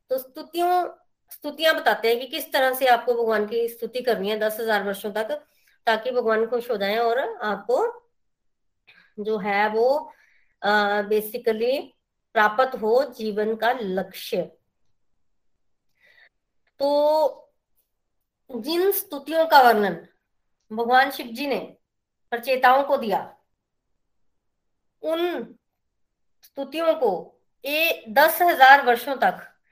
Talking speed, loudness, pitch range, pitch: 110 wpm, -22 LUFS, 220-300 Hz, 250 Hz